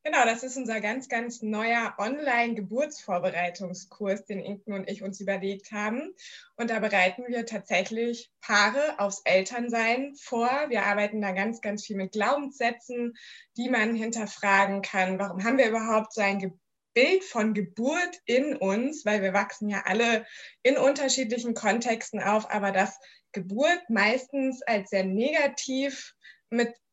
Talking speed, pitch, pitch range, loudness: 145 wpm, 225 Hz, 200-245 Hz, -27 LUFS